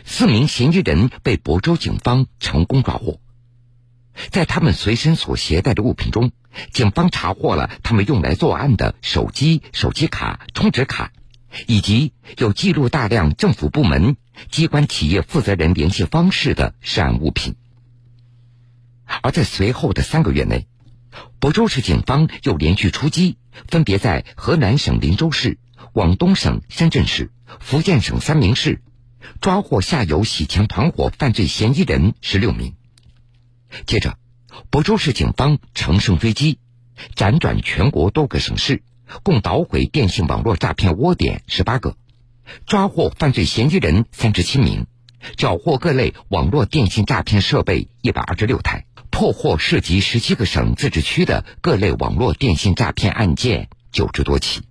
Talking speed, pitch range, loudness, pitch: 240 characters per minute, 100-135 Hz, -17 LUFS, 120 Hz